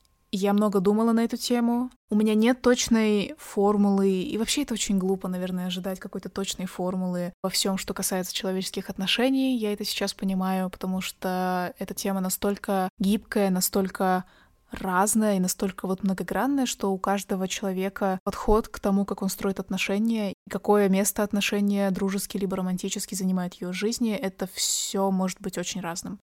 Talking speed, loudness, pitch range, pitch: 160 wpm, -26 LUFS, 190-210 Hz, 200 Hz